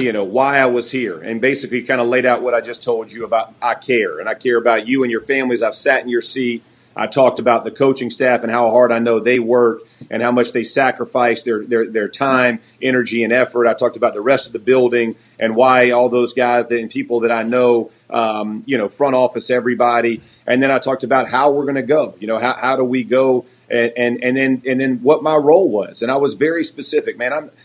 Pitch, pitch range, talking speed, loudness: 125 Hz, 120-130 Hz, 250 wpm, -16 LUFS